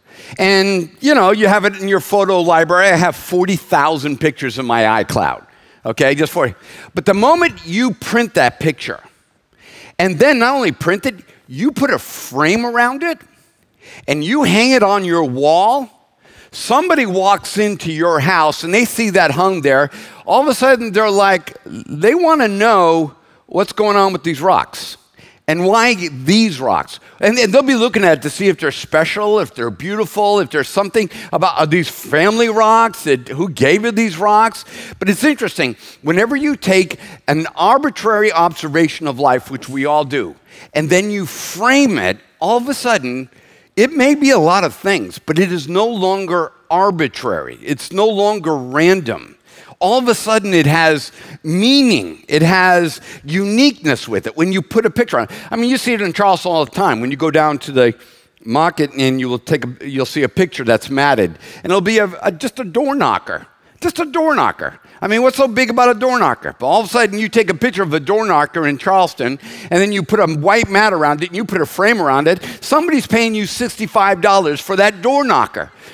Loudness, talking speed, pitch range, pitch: -14 LUFS, 200 wpm, 155-225 Hz, 190 Hz